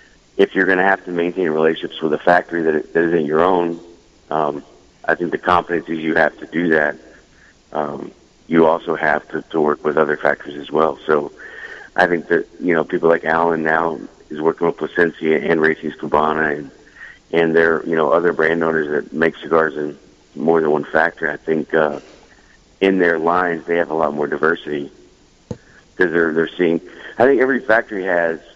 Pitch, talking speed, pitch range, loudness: 80 Hz, 190 wpm, 80-85 Hz, -18 LUFS